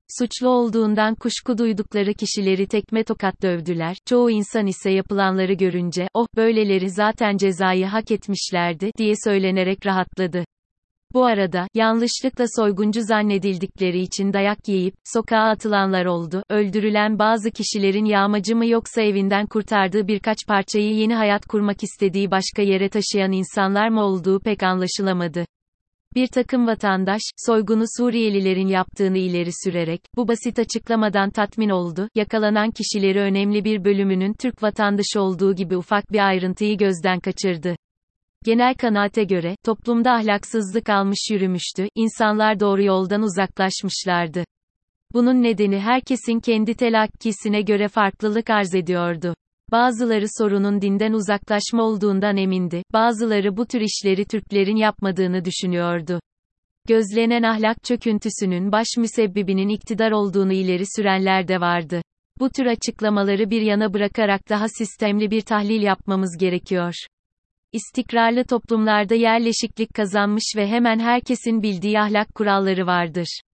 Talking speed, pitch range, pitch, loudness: 120 wpm, 190-225 Hz, 210 Hz, -20 LUFS